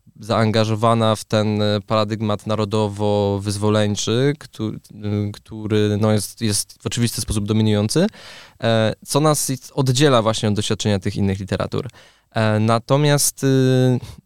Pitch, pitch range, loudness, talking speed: 110 Hz, 105-120 Hz, -19 LUFS, 100 wpm